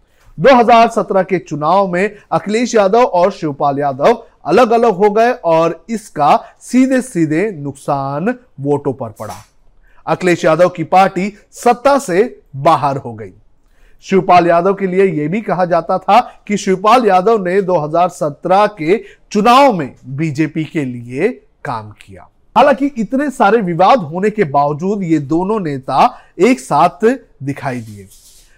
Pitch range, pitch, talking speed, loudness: 145-215 Hz, 180 Hz, 140 wpm, -13 LUFS